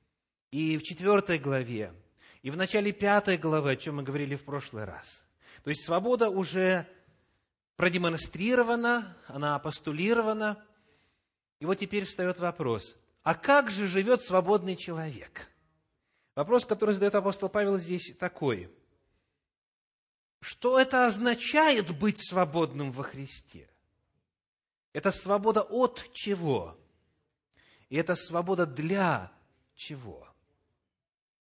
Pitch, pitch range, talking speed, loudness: 180 Hz, 140-205 Hz, 110 wpm, -29 LUFS